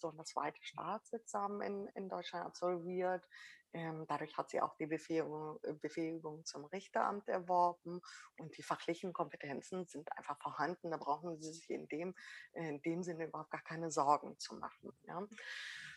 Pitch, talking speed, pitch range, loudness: 170 Hz, 160 wpm, 155-185 Hz, -42 LUFS